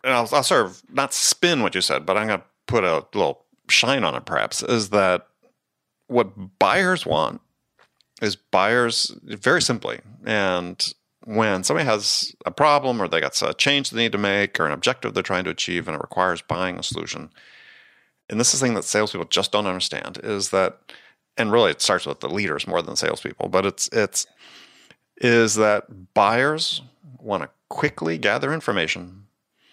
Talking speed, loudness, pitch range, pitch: 185 wpm, -21 LUFS, 95-125 Hz, 105 Hz